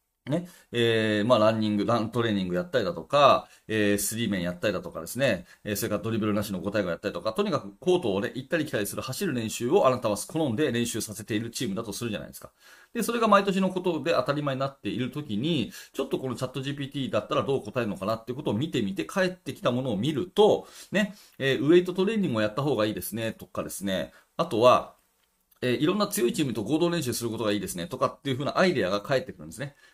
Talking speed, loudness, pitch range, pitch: 535 characters per minute, -27 LUFS, 105-155 Hz, 120 Hz